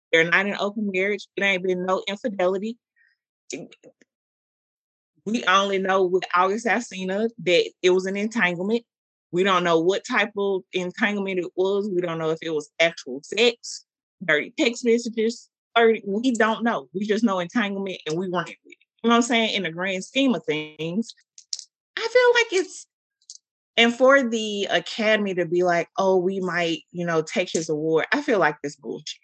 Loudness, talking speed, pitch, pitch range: -22 LUFS, 180 wpm, 195 Hz, 175-230 Hz